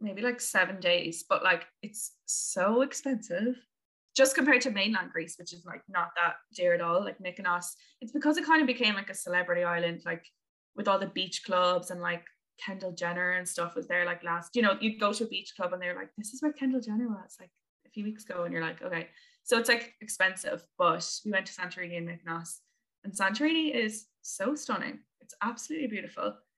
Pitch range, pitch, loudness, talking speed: 175-245 Hz, 195 Hz, -30 LUFS, 215 wpm